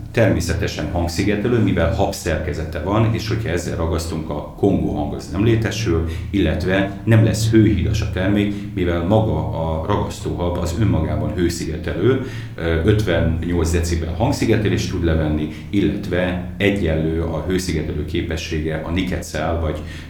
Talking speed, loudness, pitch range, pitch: 125 wpm, -20 LUFS, 80-105 Hz, 90 Hz